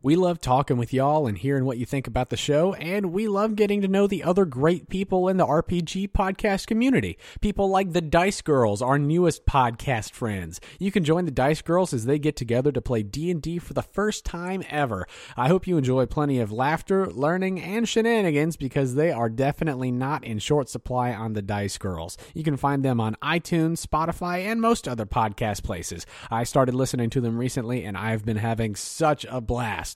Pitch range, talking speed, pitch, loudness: 125-180 Hz, 205 wpm, 145 Hz, -24 LUFS